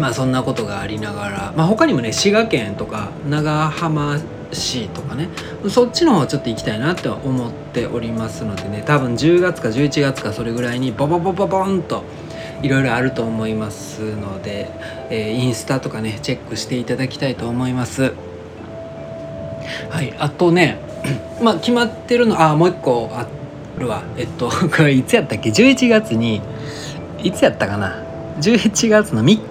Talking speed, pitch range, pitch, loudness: 325 characters per minute, 110-165 Hz, 130 Hz, -18 LUFS